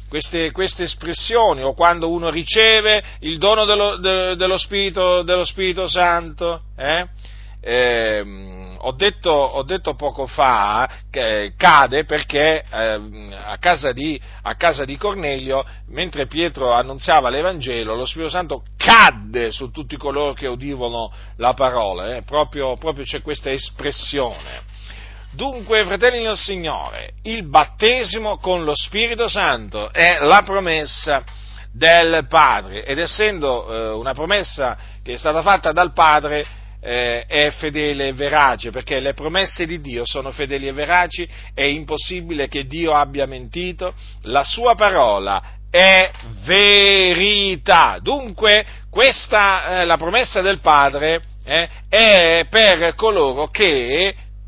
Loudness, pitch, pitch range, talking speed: -16 LUFS, 155 Hz, 130-185 Hz, 130 wpm